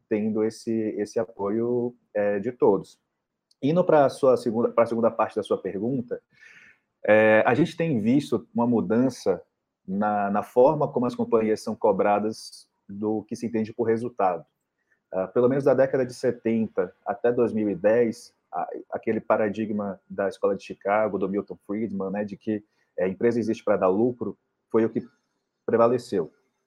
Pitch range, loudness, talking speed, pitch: 105-120 Hz, -25 LUFS, 155 wpm, 110 Hz